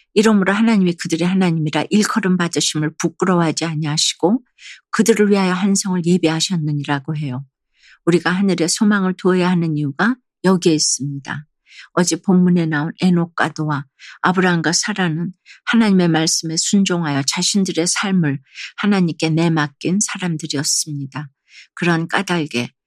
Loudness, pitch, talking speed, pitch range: -17 LUFS, 170 Hz, 350 characters per minute, 155-185 Hz